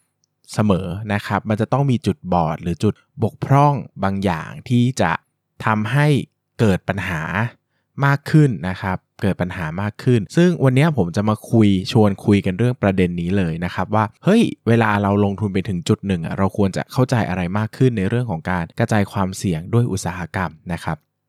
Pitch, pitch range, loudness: 100 Hz, 95-120 Hz, -19 LUFS